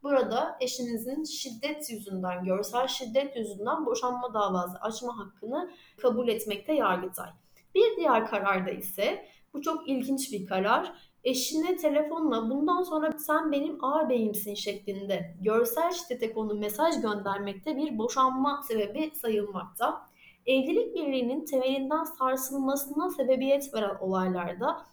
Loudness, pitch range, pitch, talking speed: -29 LUFS, 210-300 Hz, 255 Hz, 115 wpm